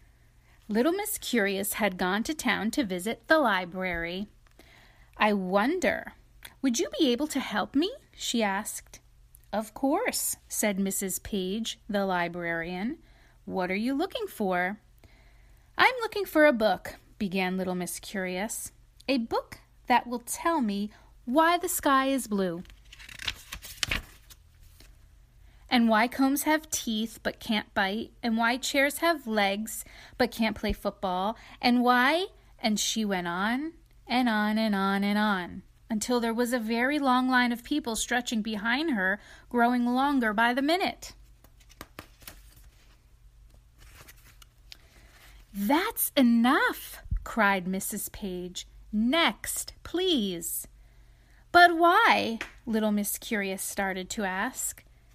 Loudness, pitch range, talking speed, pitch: -27 LUFS, 200-270 Hz, 125 wpm, 230 Hz